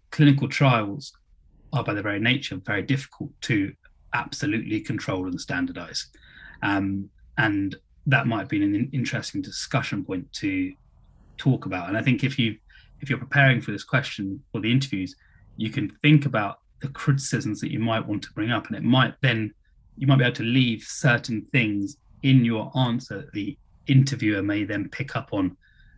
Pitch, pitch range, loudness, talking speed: 120 Hz, 105-140 Hz, -25 LUFS, 175 wpm